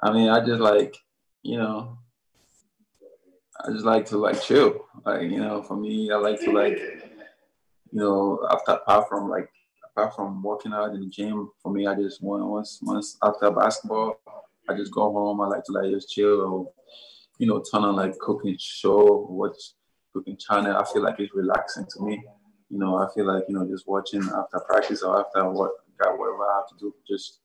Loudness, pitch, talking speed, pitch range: -24 LUFS, 105 Hz, 205 wpm, 100-110 Hz